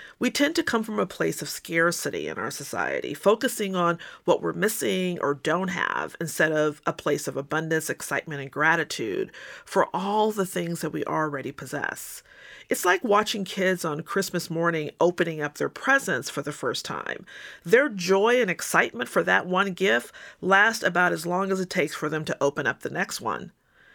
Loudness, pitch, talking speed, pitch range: -25 LUFS, 175 Hz, 190 wpm, 155-200 Hz